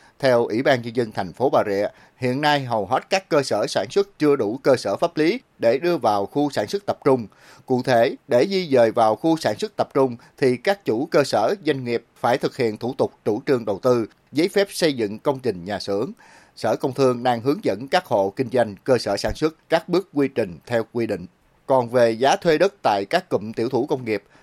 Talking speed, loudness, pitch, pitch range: 245 wpm, -21 LUFS, 130 Hz, 115-150 Hz